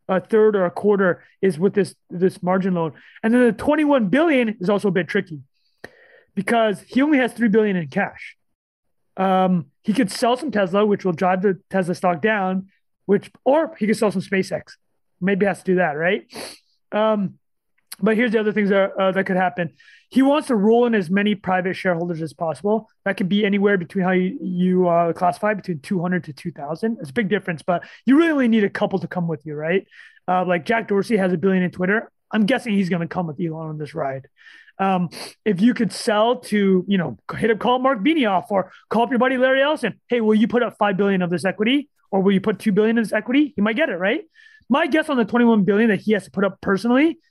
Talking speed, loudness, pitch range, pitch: 235 wpm, -20 LUFS, 185-230 Hz, 200 Hz